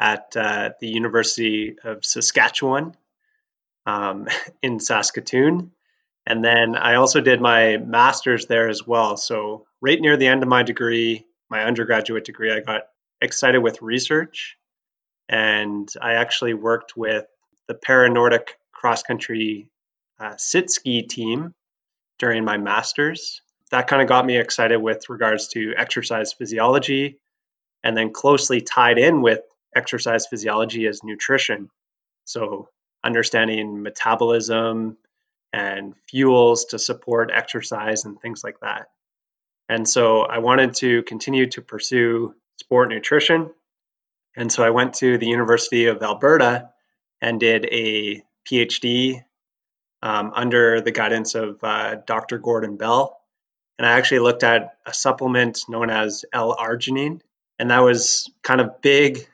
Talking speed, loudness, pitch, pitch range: 130 wpm, -19 LUFS, 115 Hz, 110-130 Hz